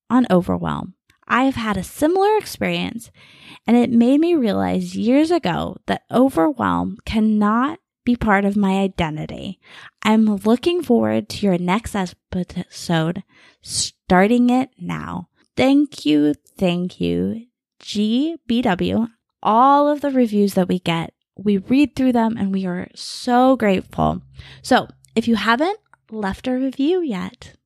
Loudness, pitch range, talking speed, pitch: -19 LUFS, 180-255 Hz, 135 wpm, 215 Hz